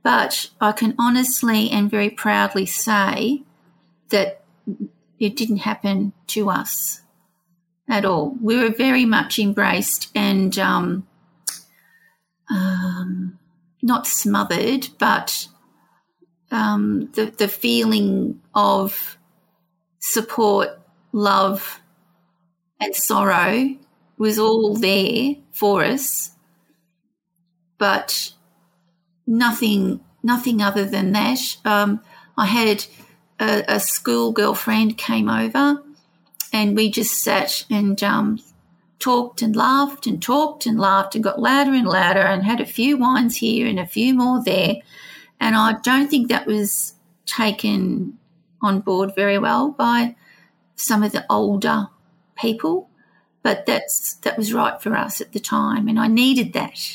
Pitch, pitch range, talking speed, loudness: 210 Hz, 185-230 Hz, 120 wpm, -19 LUFS